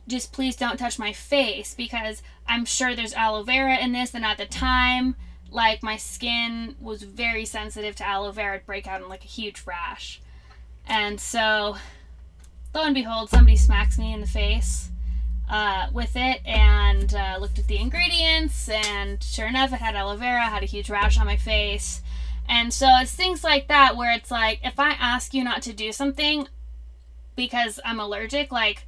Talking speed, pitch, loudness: 185 wpm, 220 Hz, -23 LUFS